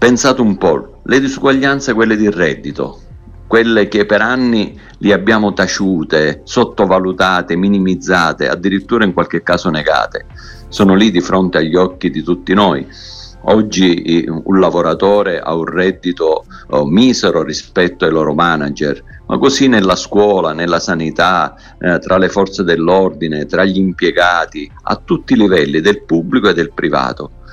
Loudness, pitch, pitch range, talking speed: -13 LUFS, 95 Hz, 85-105 Hz, 140 wpm